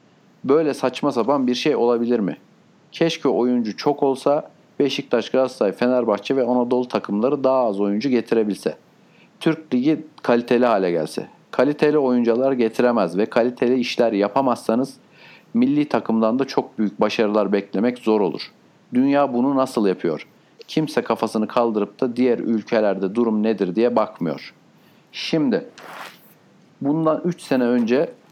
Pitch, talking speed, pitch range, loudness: 125 Hz, 130 wpm, 110-135 Hz, -20 LUFS